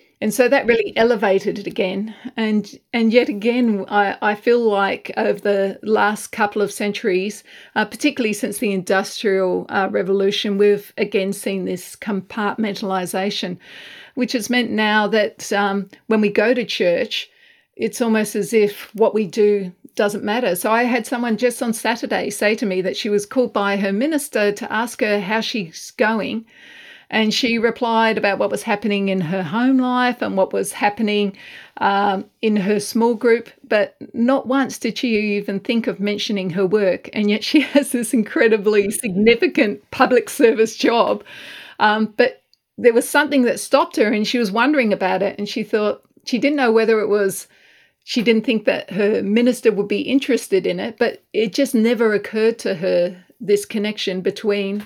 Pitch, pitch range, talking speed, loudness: 220 Hz, 205-240 Hz, 175 wpm, -19 LUFS